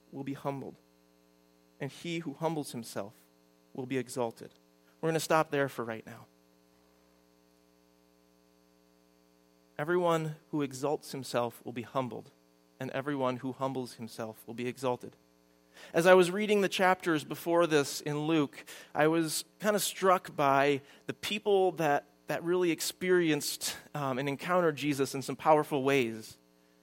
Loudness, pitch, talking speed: -31 LUFS, 135 Hz, 145 wpm